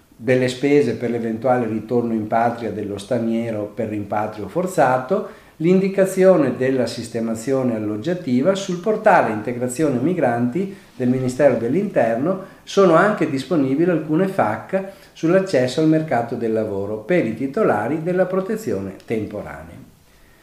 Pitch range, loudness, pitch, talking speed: 115-180 Hz, -20 LUFS, 130 Hz, 115 wpm